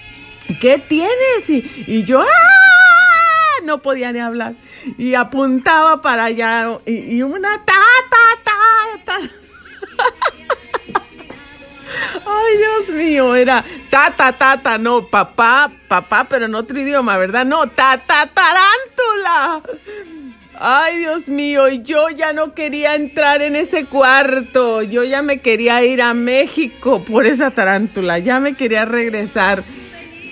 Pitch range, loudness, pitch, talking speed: 240-330 Hz, -13 LUFS, 275 Hz, 135 wpm